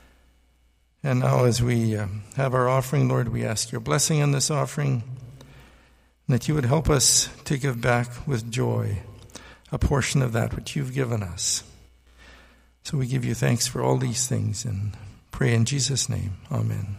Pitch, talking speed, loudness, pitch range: 120 Hz, 175 wpm, -24 LUFS, 105-130 Hz